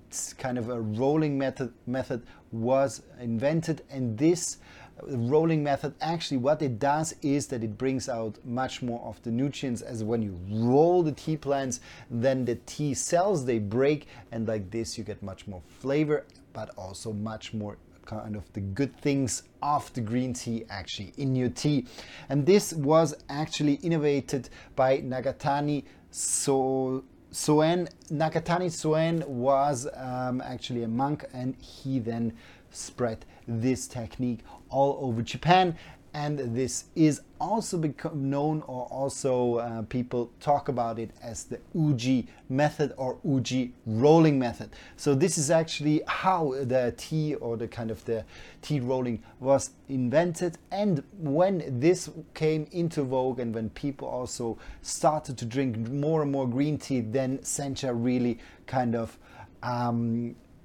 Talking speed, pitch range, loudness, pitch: 150 wpm, 115-145 Hz, -28 LUFS, 130 Hz